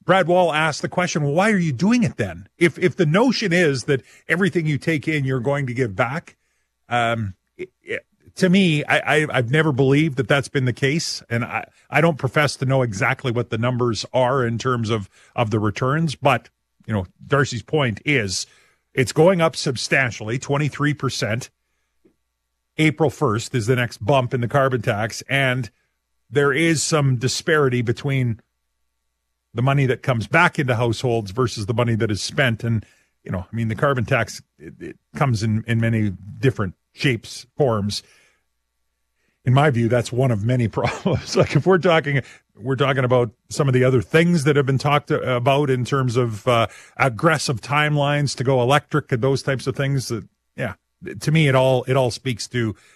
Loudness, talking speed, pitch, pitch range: -20 LUFS, 190 wpm, 130 Hz, 115-150 Hz